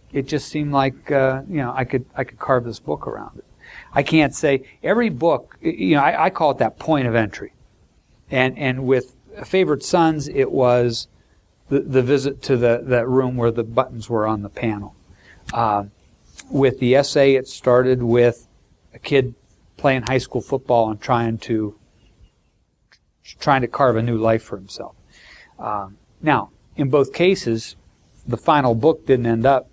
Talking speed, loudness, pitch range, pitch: 175 wpm, -19 LUFS, 110-135 Hz, 125 Hz